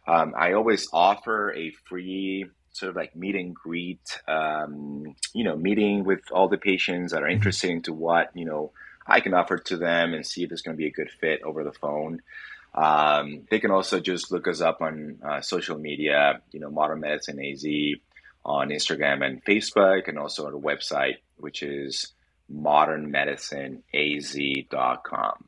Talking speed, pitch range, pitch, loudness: 175 wpm, 75-90 Hz, 75 Hz, -25 LUFS